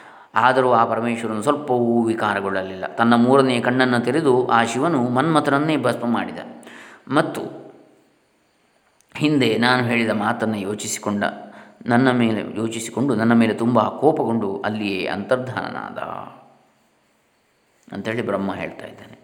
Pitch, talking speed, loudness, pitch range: 115 Hz, 105 wpm, -20 LUFS, 105-125 Hz